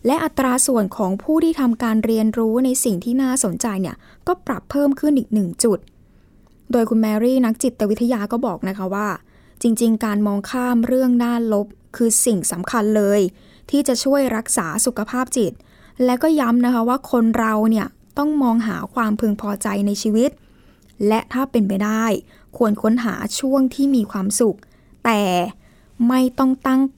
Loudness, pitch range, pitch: -19 LUFS, 210-255 Hz, 230 Hz